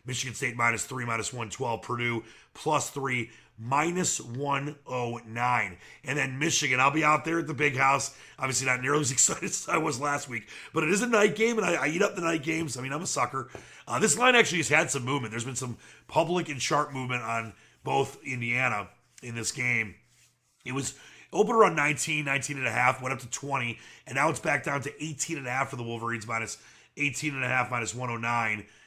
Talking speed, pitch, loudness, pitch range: 220 wpm, 130 Hz, -27 LUFS, 120-150 Hz